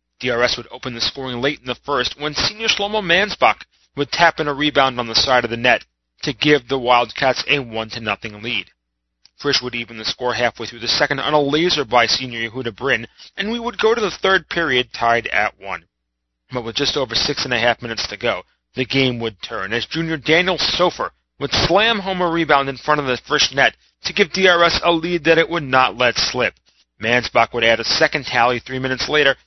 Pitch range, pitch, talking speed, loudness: 120-160 Hz, 130 Hz, 220 wpm, -18 LUFS